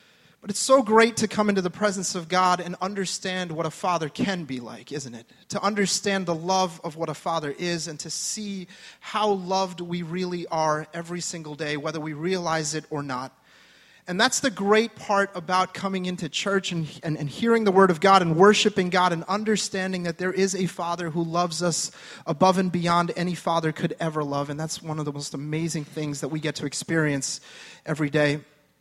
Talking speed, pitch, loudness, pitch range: 210 wpm, 175 Hz, -25 LUFS, 160-190 Hz